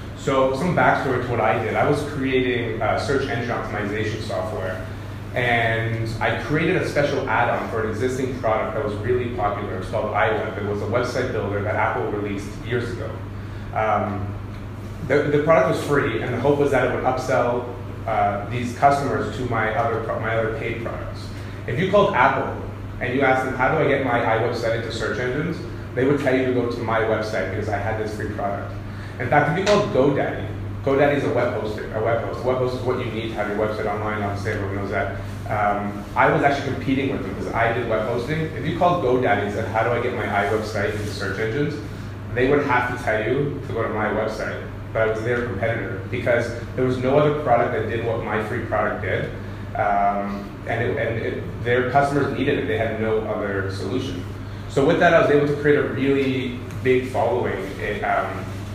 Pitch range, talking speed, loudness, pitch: 105-130 Hz, 220 wpm, -22 LUFS, 115 Hz